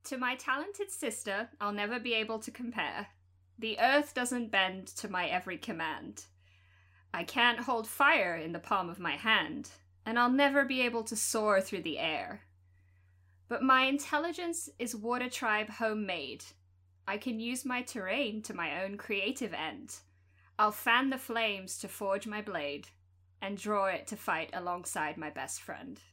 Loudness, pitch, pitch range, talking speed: -32 LUFS, 210 Hz, 145-245 Hz, 165 wpm